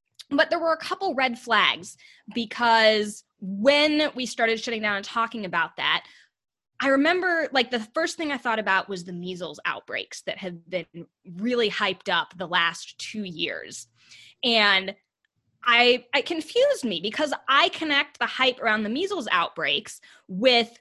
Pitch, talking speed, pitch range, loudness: 235 Hz, 160 wpm, 200-280 Hz, -23 LUFS